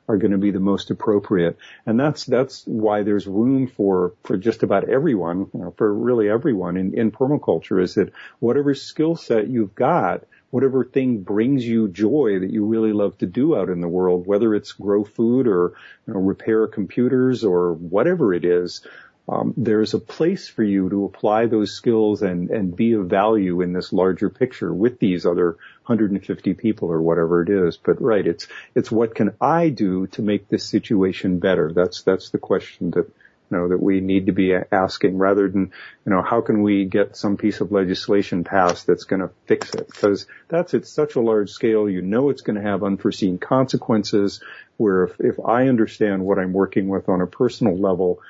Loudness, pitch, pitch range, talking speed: -20 LUFS, 100 Hz, 95-110 Hz, 200 wpm